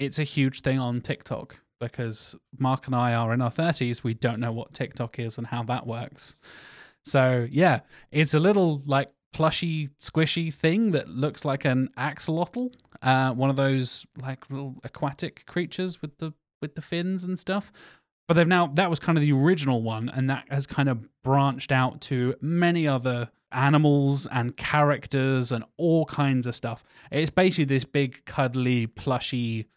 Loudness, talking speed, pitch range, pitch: -25 LUFS, 175 wpm, 125-160 Hz, 140 Hz